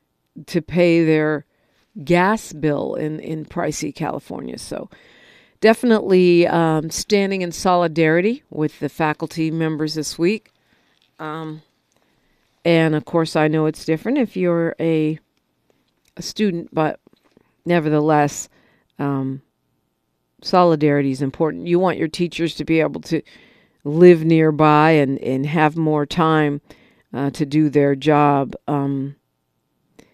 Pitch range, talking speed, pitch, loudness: 150-170 Hz, 120 wpm, 155 Hz, -18 LUFS